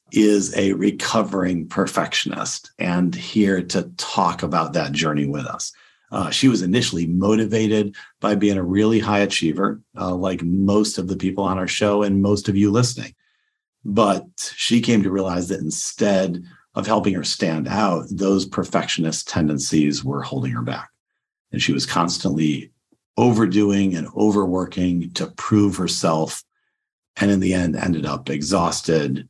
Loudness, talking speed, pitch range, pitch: -20 LUFS, 150 wpm, 90-105 Hz, 95 Hz